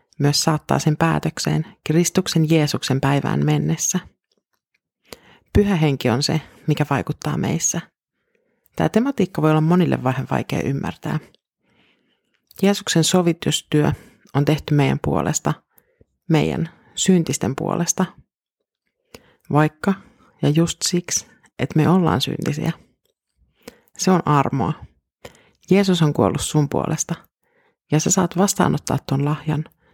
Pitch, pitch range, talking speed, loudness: 160 Hz, 145-180 Hz, 110 wpm, -20 LUFS